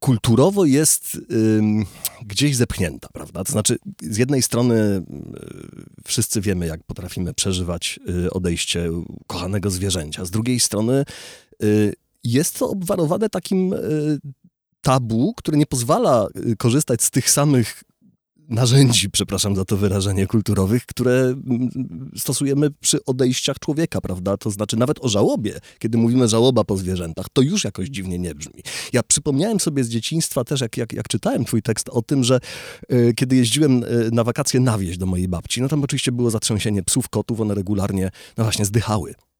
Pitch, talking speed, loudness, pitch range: 120 Hz, 160 wpm, -20 LUFS, 100-135 Hz